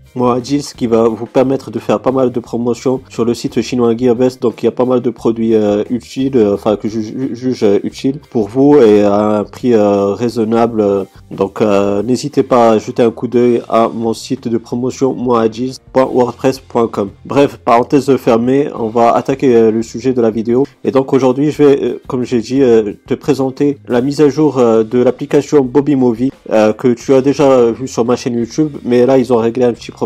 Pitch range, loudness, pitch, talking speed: 115-130 Hz, -13 LUFS, 120 Hz, 215 wpm